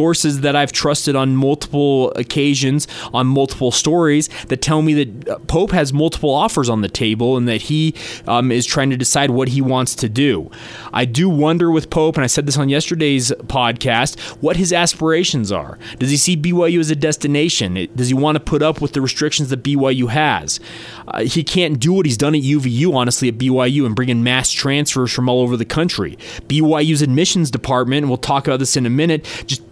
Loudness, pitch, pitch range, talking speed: -16 LUFS, 140 Hz, 125-155 Hz, 210 wpm